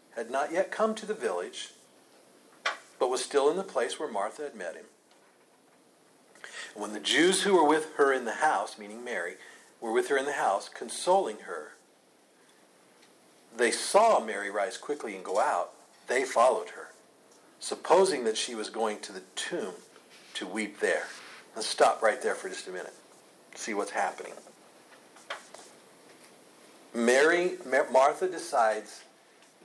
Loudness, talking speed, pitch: -28 LUFS, 150 wpm, 375 Hz